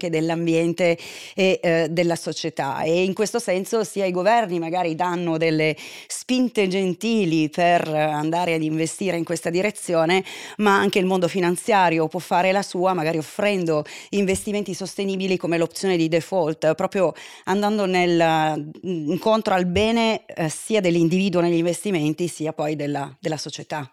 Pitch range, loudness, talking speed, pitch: 160-190 Hz, -22 LUFS, 145 wpm, 175 Hz